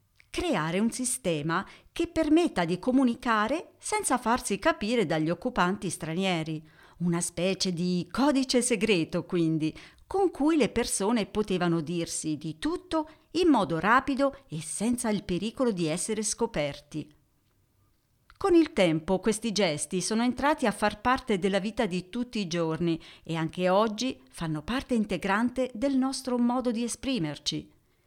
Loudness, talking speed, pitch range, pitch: -28 LUFS, 135 wpm, 170-250 Hz, 210 Hz